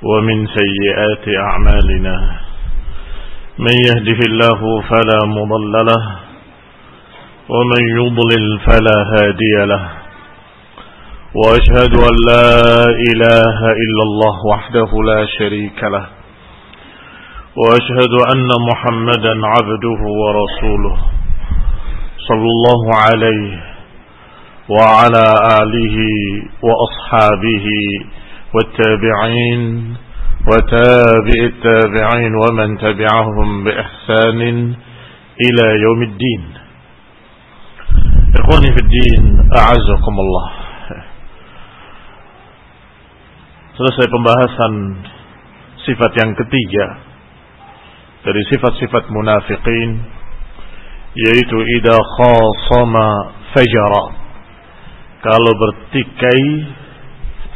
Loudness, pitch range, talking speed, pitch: -12 LUFS, 105-120 Hz, 65 wpm, 110 Hz